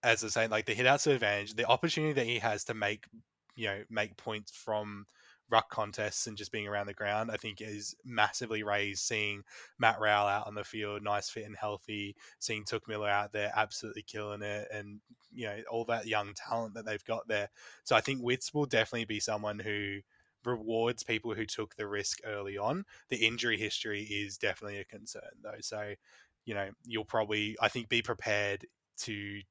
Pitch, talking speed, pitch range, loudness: 105 Hz, 200 wpm, 105-115 Hz, -34 LUFS